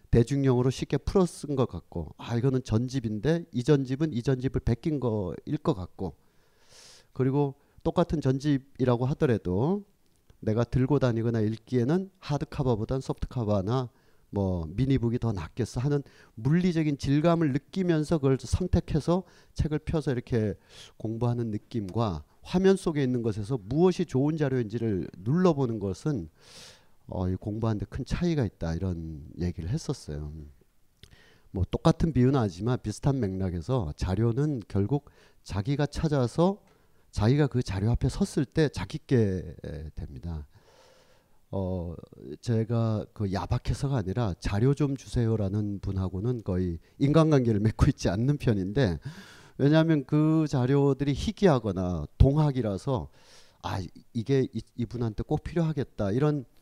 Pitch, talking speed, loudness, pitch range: 125 Hz, 300 characters per minute, -28 LUFS, 105-145 Hz